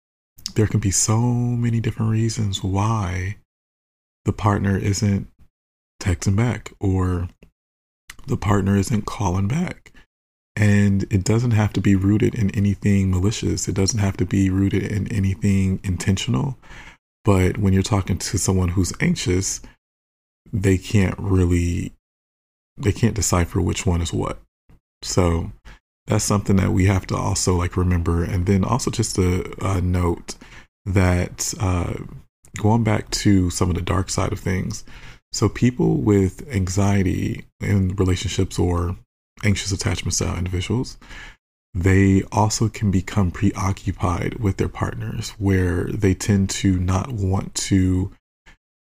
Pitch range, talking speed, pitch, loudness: 90-105 Hz, 135 wpm, 95 Hz, -21 LUFS